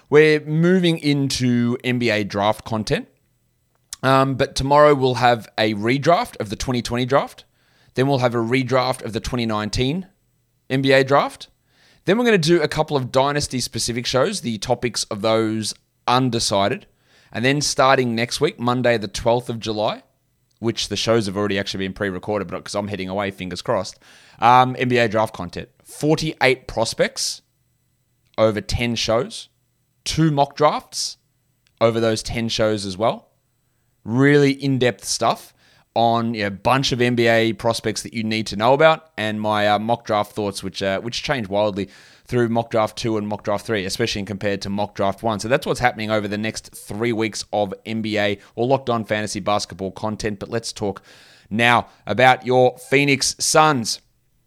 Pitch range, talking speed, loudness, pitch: 105-130 Hz, 170 wpm, -20 LUFS, 115 Hz